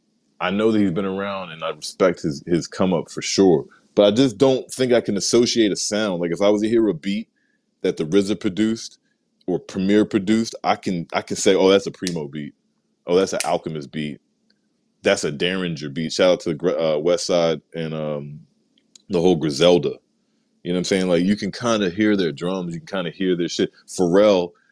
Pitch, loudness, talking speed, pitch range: 95 Hz, -20 LUFS, 225 wpm, 85-105 Hz